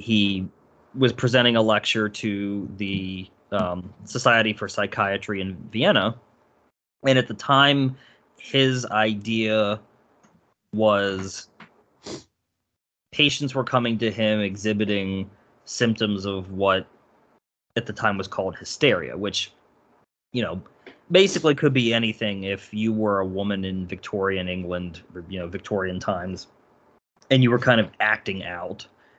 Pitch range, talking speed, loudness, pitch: 95-115 Hz, 125 wpm, -23 LUFS, 105 Hz